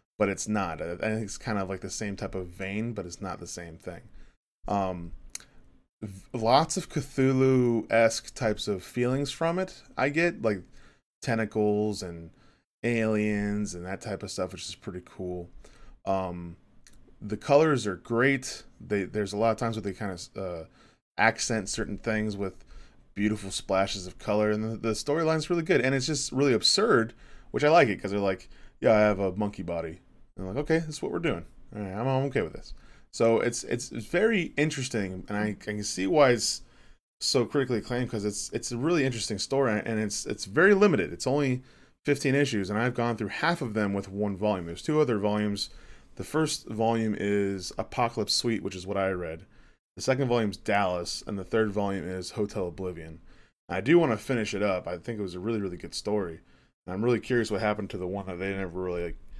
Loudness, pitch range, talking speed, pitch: -28 LUFS, 95-120 Hz, 205 wpm, 105 Hz